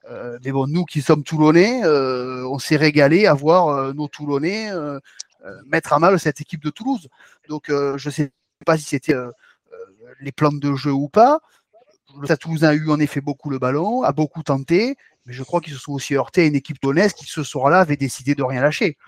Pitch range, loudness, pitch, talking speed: 140-165 Hz, -19 LUFS, 150 Hz, 230 wpm